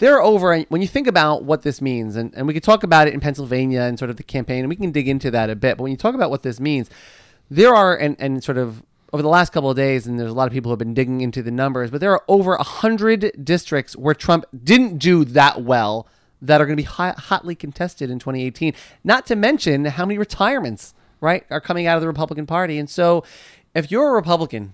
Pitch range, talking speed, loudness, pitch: 130-175 Hz, 255 wpm, -18 LUFS, 150 Hz